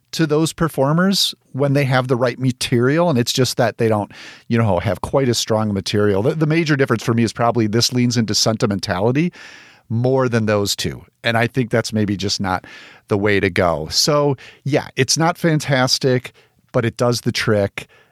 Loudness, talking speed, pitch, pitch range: -18 LUFS, 195 wpm, 120 Hz, 110-135 Hz